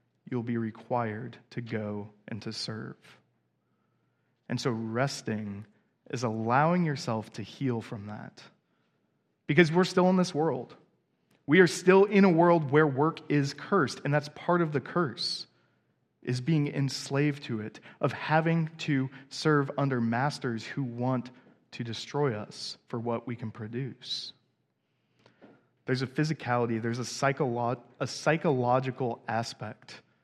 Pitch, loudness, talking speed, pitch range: 130 Hz, -29 LUFS, 140 wpm, 115-150 Hz